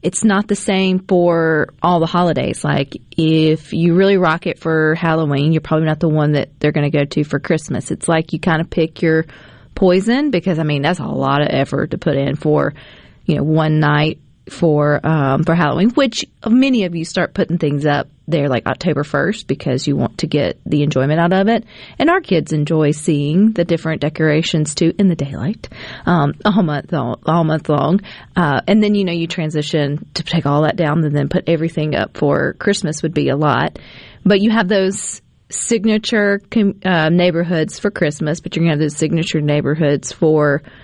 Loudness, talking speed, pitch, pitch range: -16 LUFS, 205 wpm, 160 Hz, 150-180 Hz